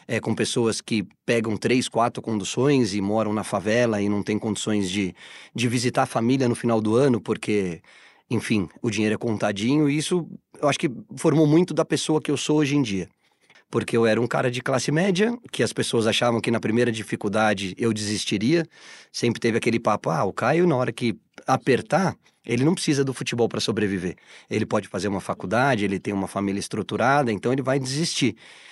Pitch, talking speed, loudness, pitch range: 115 Hz, 200 wpm, -23 LUFS, 105-135 Hz